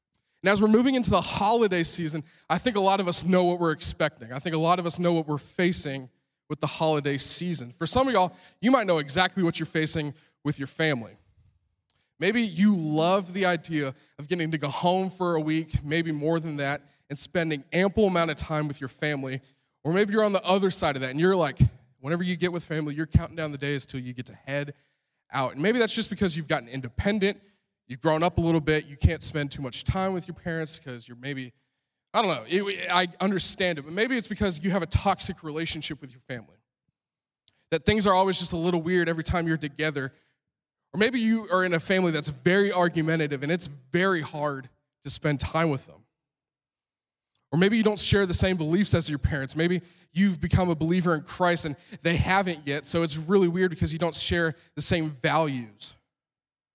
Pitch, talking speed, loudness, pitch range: 165 Hz, 220 wpm, -26 LUFS, 145-185 Hz